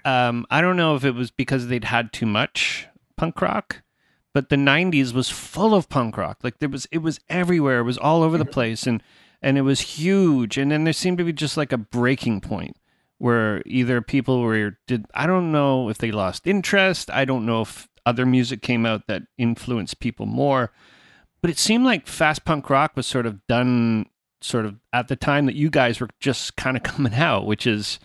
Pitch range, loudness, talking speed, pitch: 120-155 Hz, -21 LUFS, 215 wpm, 130 Hz